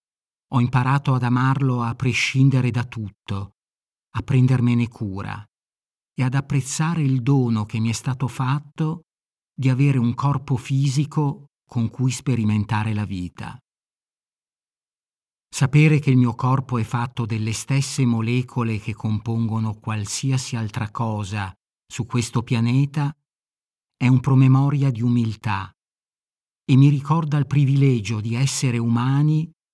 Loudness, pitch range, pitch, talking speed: -21 LUFS, 115-135 Hz, 125 Hz, 125 wpm